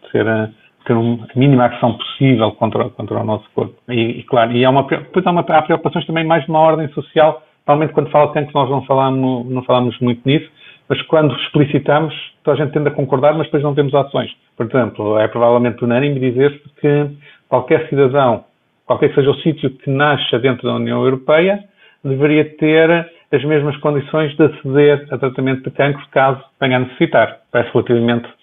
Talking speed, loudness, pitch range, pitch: 190 wpm, -15 LUFS, 125-155 Hz, 140 Hz